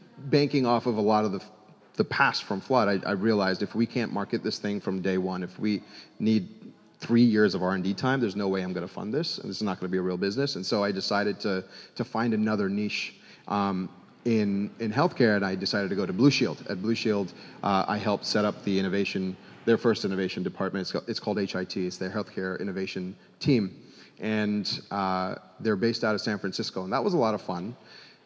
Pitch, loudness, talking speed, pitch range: 100 Hz, -28 LUFS, 230 wpm, 95-115 Hz